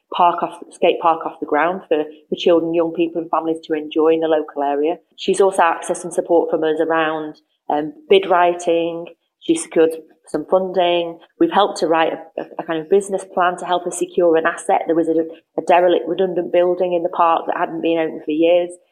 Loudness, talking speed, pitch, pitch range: -18 LUFS, 215 wpm, 170 Hz, 160-175 Hz